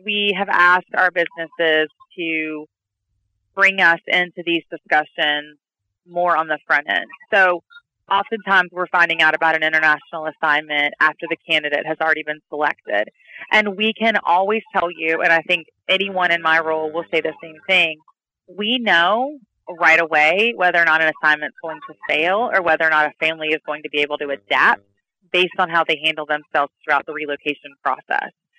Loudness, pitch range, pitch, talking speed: -18 LUFS, 155-180 Hz, 160 Hz, 180 wpm